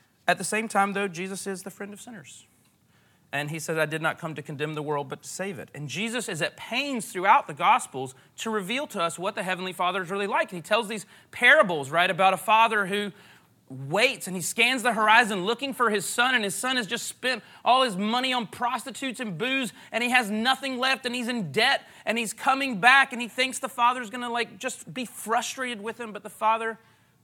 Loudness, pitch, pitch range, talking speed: -25 LUFS, 220 Hz, 185-245 Hz, 235 wpm